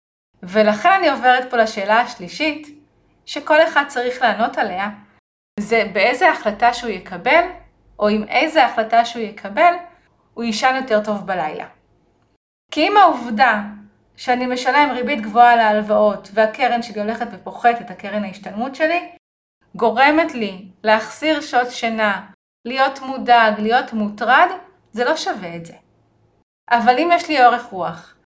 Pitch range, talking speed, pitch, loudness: 210-280 Hz, 130 wpm, 235 Hz, -17 LUFS